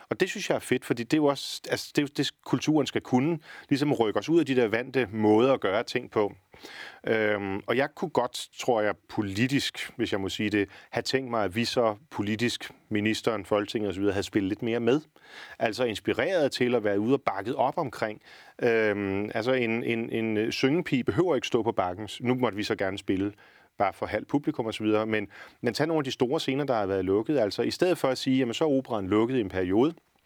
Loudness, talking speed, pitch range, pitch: -27 LUFS, 235 wpm, 105-130 Hz, 115 Hz